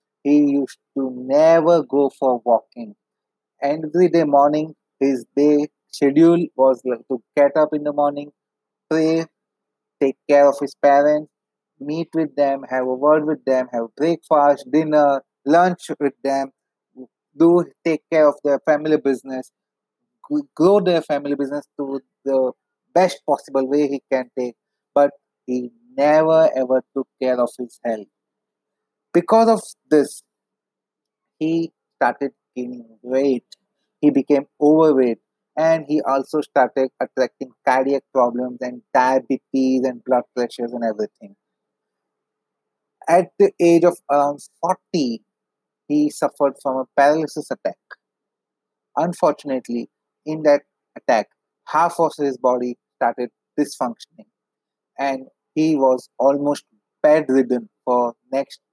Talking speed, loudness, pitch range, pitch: 125 wpm, -19 LUFS, 130-155 Hz, 145 Hz